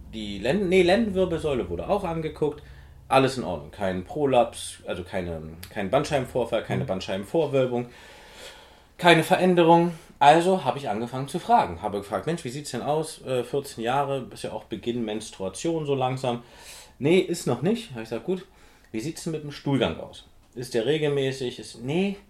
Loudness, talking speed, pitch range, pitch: -25 LUFS, 175 wpm, 115-170 Hz, 140 Hz